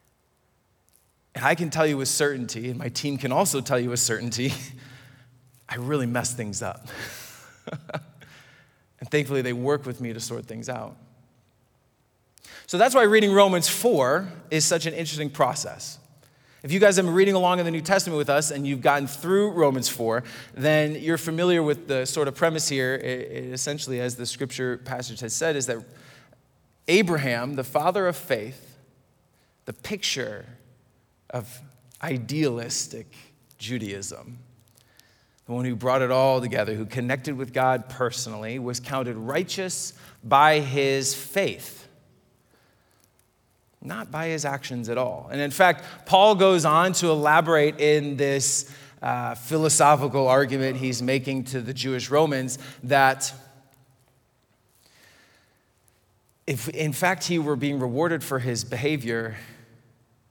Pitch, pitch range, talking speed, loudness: 135 Hz, 125-150 Hz, 145 wpm, -24 LUFS